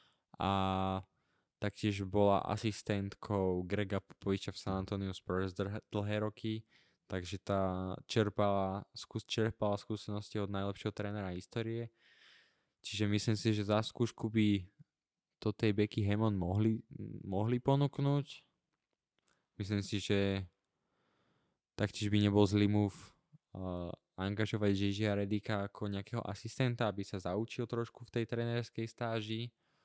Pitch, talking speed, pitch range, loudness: 105 Hz, 115 wpm, 100-110 Hz, -36 LUFS